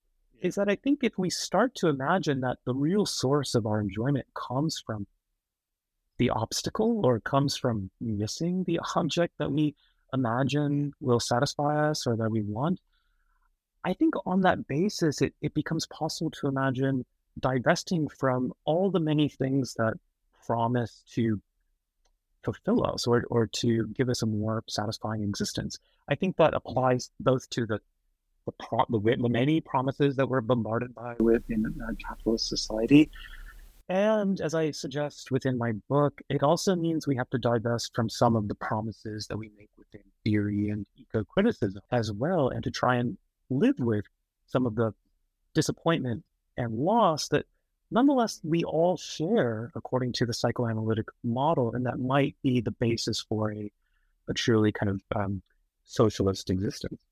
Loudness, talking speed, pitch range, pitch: -28 LUFS, 160 wpm, 110-150 Hz, 125 Hz